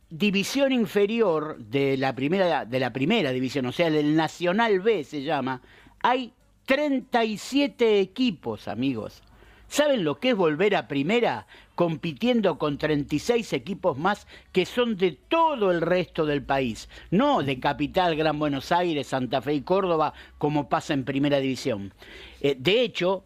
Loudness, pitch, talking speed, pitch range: -25 LUFS, 165 Hz, 145 wpm, 140-205 Hz